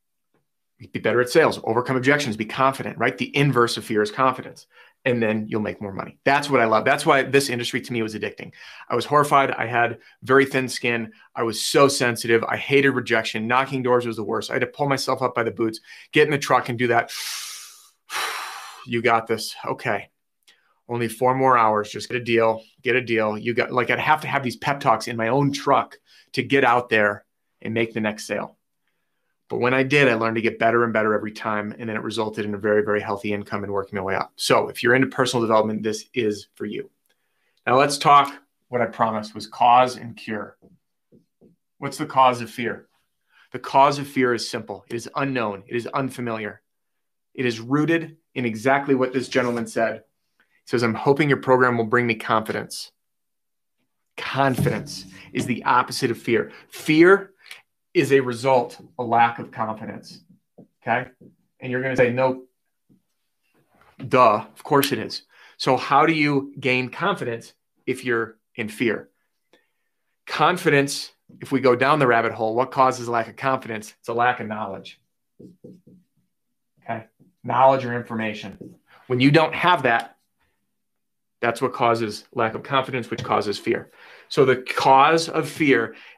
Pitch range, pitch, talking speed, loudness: 110-135 Hz, 120 Hz, 190 wpm, -21 LUFS